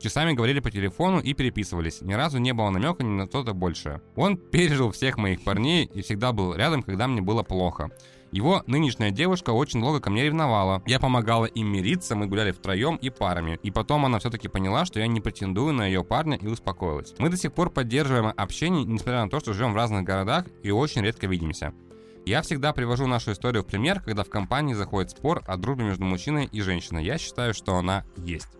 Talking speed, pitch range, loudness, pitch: 210 wpm, 95-135 Hz, -26 LUFS, 110 Hz